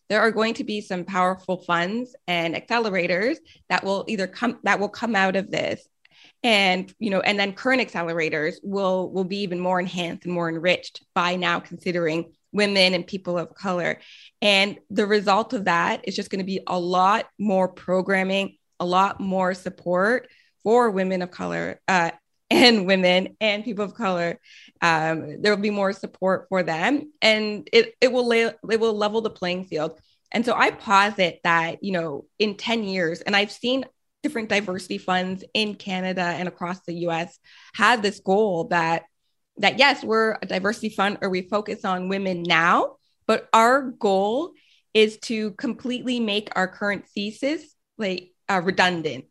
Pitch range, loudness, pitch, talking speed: 180-220 Hz, -23 LUFS, 195 Hz, 175 wpm